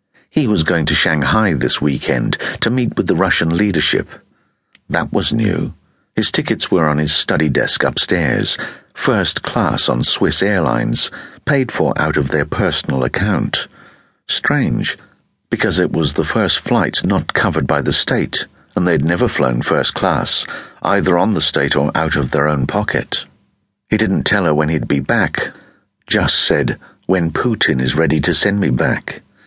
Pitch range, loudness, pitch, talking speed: 75-95 Hz, -15 LUFS, 80 Hz, 165 wpm